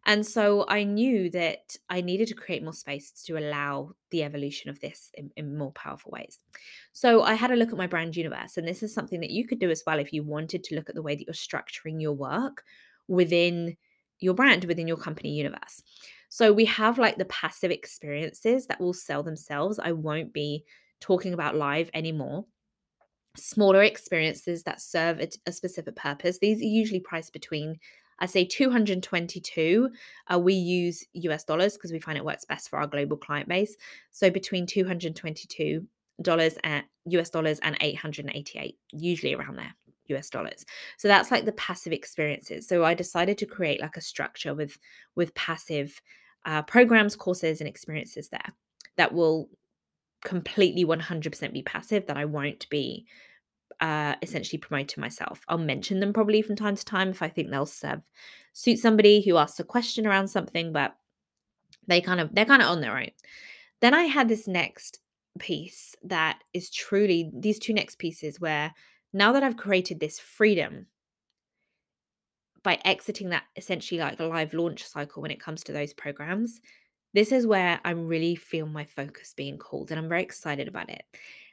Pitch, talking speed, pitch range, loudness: 175 Hz, 180 wpm, 155-200 Hz, -27 LUFS